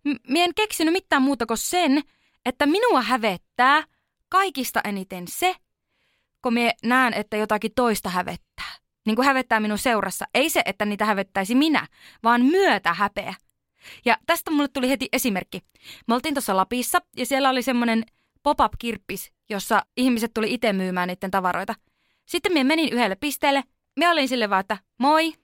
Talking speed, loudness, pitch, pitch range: 160 wpm, -22 LUFS, 250 Hz, 215-290 Hz